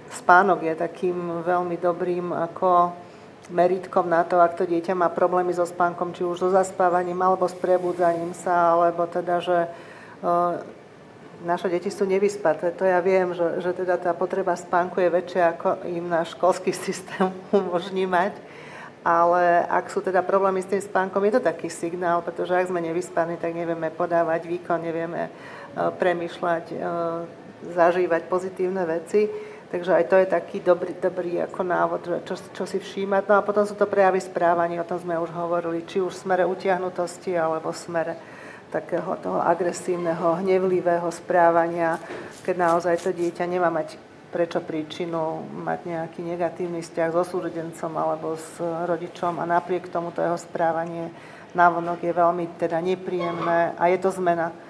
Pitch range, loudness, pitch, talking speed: 170-185 Hz, -24 LUFS, 175 Hz, 160 wpm